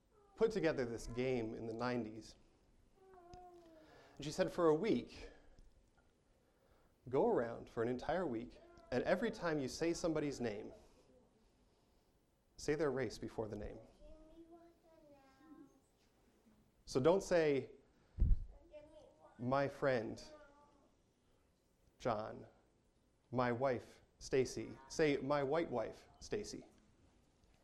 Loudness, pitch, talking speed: -40 LUFS, 165 Hz, 100 wpm